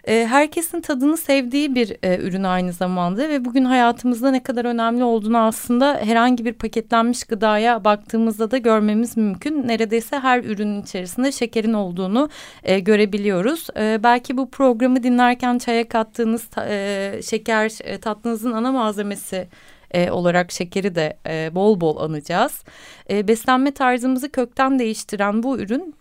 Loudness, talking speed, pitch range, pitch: -19 LUFS, 120 wpm, 210-255 Hz, 230 Hz